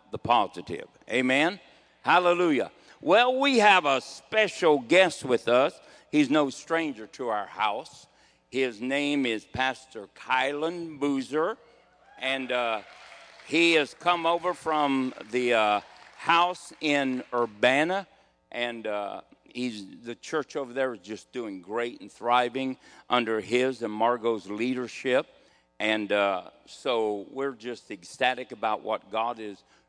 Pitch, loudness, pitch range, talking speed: 130 Hz, -26 LUFS, 115-150 Hz, 130 wpm